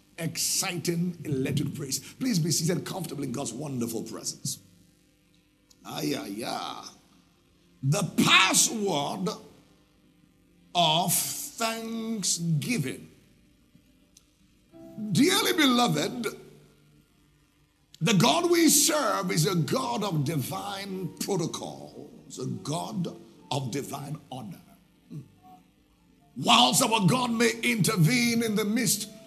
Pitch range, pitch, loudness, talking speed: 140-225 Hz, 175 Hz, -26 LUFS, 90 wpm